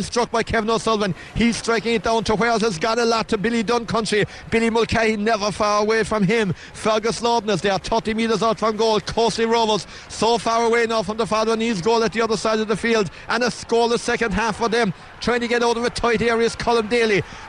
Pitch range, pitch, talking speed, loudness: 220-230 Hz, 225 Hz, 235 wpm, -20 LUFS